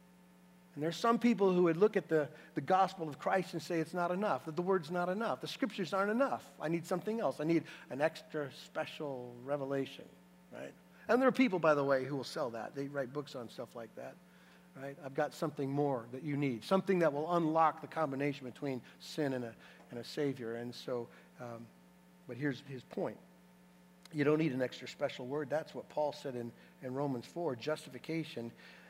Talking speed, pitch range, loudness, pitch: 210 wpm, 125-165 Hz, -36 LUFS, 145 Hz